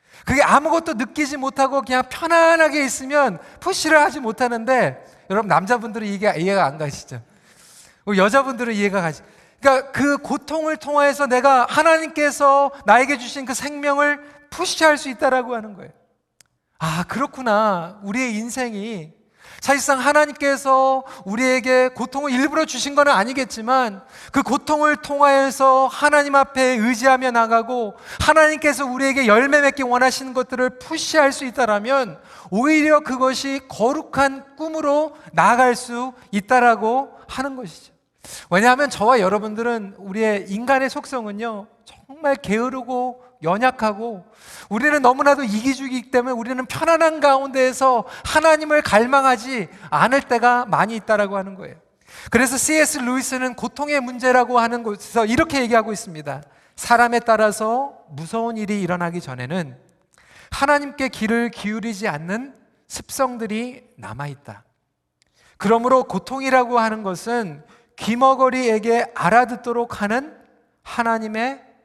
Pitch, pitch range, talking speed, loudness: 255 Hz, 220-275 Hz, 320 characters per minute, -18 LUFS